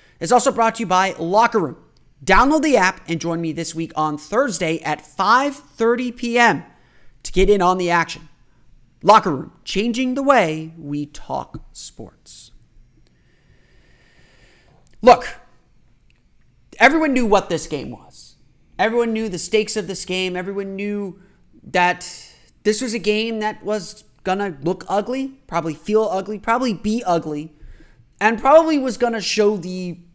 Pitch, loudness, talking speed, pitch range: 200 Hz, -19 LUFS, 150 wpm, 170-230 Hz